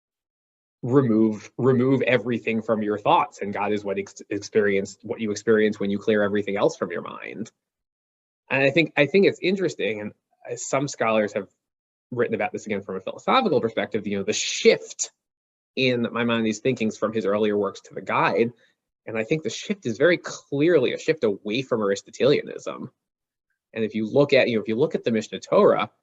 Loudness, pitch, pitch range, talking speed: -23 LUFS, 110 Hz, 105-130 Hz, 200 wpm